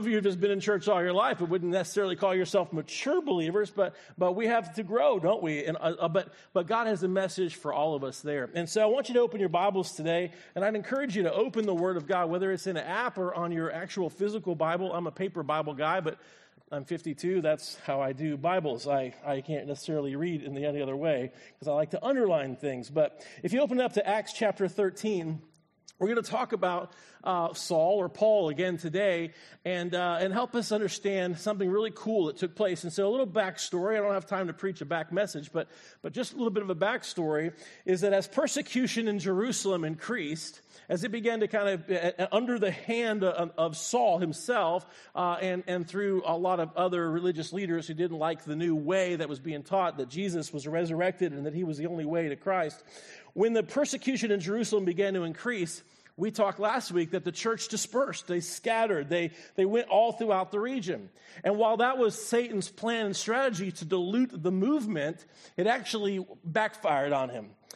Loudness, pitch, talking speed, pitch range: -30 LUFS, 185 Hz, 220 wpm, 165-210 Hz